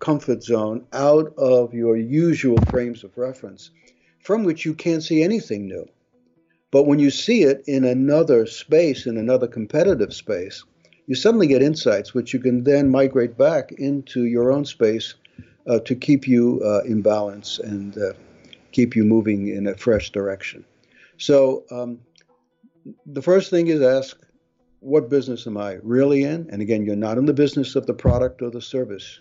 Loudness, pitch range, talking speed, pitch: -20 LUFS, 110-145 Hz, 175 wpm, 125 Hz